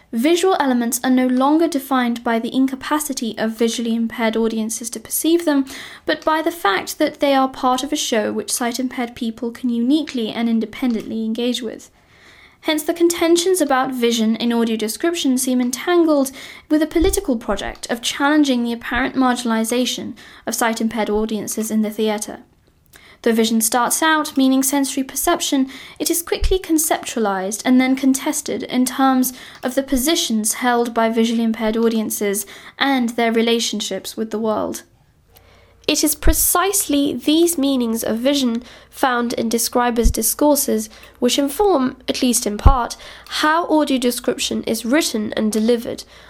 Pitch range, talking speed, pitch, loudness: 230-295 Hz, 150 wpm, 255 Hz, -18 LUFS